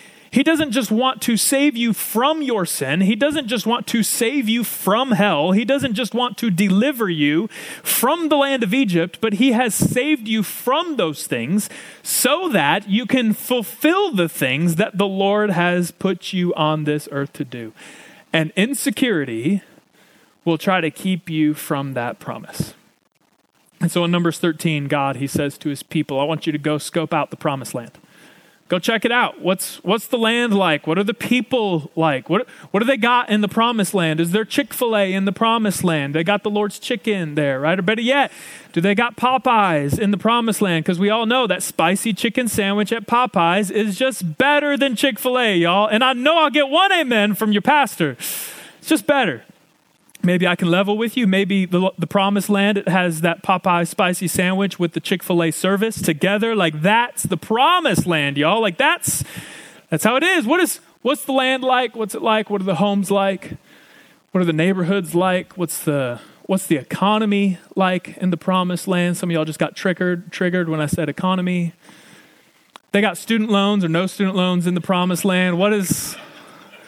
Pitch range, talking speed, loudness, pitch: 170-230 Hz, 200 wpm, -18 LUFS, 195 Hz